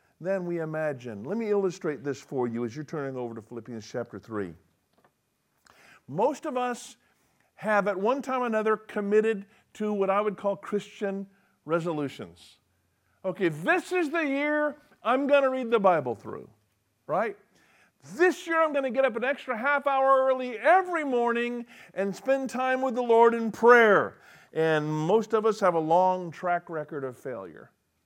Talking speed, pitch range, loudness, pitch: 170 wpm, 155-255 Hz, -27 LUFS, 205 Hz